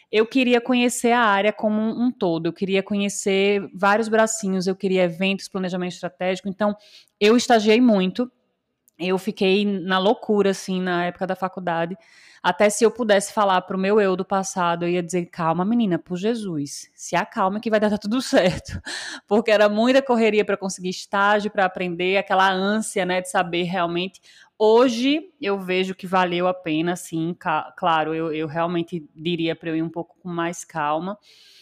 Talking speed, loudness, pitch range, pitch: 175 wpm, -21 LUFS, 180-215 Hz, 195 Hz